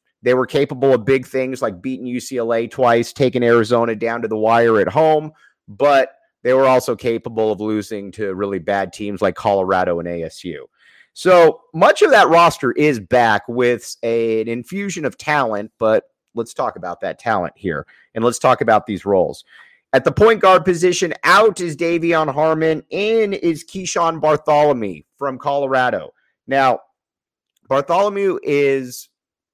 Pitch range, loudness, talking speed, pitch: 115-160 Hz, -17 LUFS, 155 wpm, 130 Hz